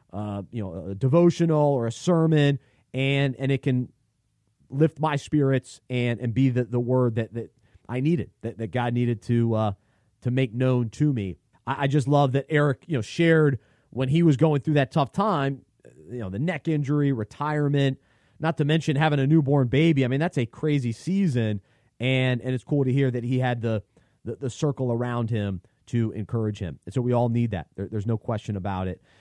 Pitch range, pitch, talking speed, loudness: 115-145 Hz, 125 Hz, 215 wpm, -25 LUFS